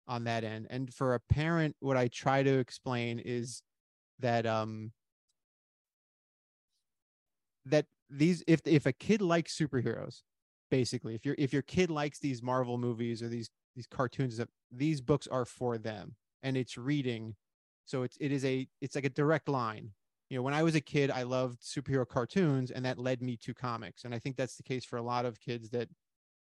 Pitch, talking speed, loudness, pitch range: 125 Hz, 190 wpm, -34 LUFS, 115-140 Hz